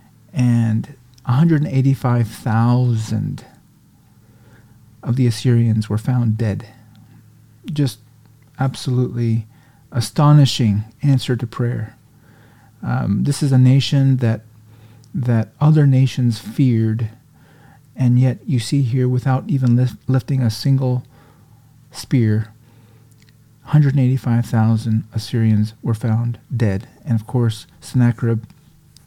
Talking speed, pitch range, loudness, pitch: 95 wpm, 115-135 Hz, -18 LUFS, 120 Hz